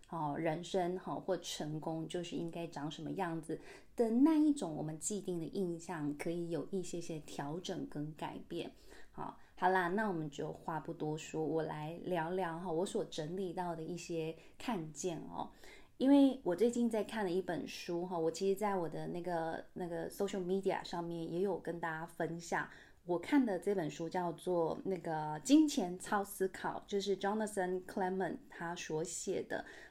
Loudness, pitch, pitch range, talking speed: -38 LUFS, 175 Hz, 165-195 Hz, 285 characters per minute